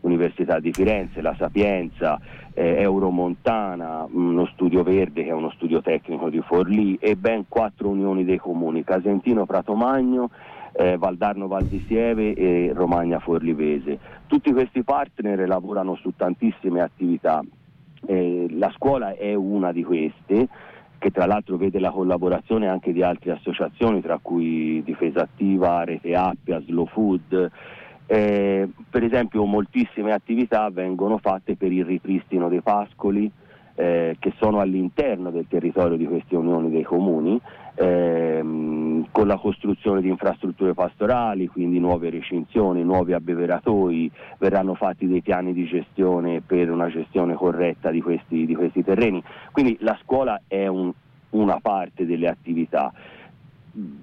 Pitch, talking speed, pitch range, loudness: 90 Hz, 135 wpm, 85-100 Hz, -22 LUFS